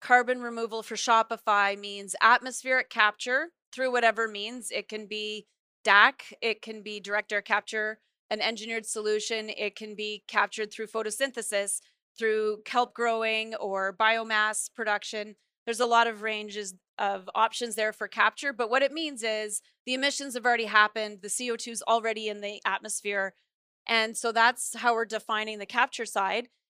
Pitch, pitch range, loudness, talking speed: 220 Hz, 210-235 Hz, -27 LUFS, 160 wpm